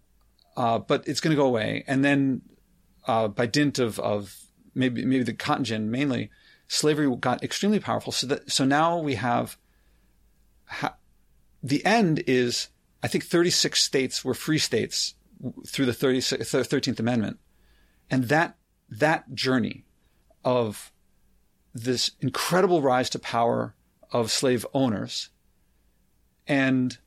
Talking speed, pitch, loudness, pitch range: 135 wpm, 130 Hz, -25 LUFS, 120-145 Hz